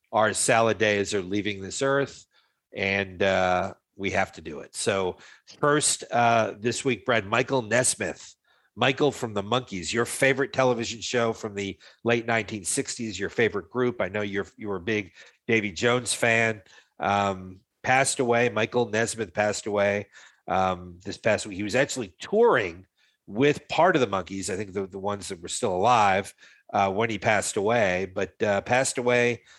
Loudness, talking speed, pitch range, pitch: -25 LUFS, 170 wpm, 100-125 Hz, 110 Hz